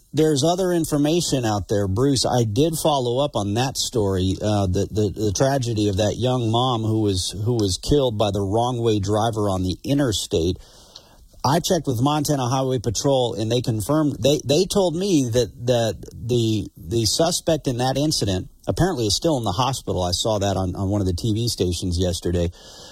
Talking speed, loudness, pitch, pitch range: 195 wpm, -21 LUFS, 115 Hz, 100-140 Hz